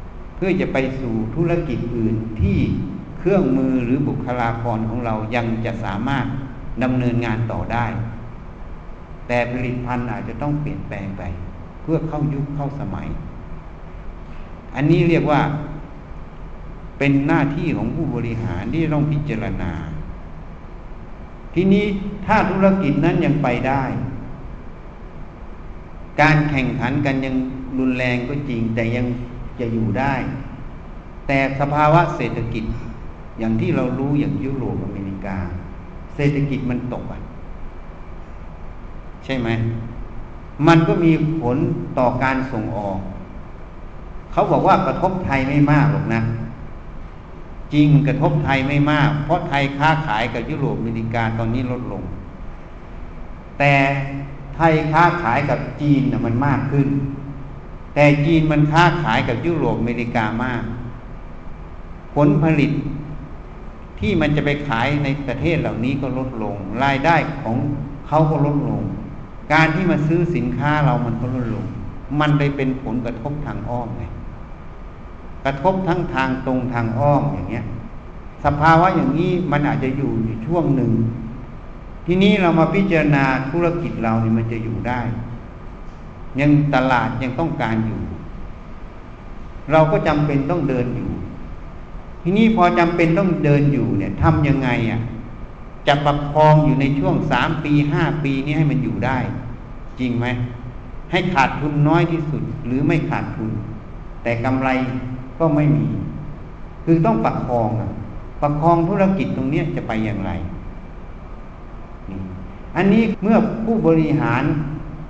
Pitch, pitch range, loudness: 130 Hz, 115-150 Hz, -19 LUFS